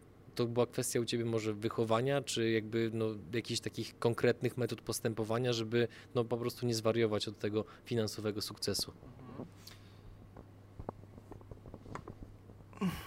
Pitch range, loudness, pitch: 105-120 Hz, -35 LUFS, 115 Hz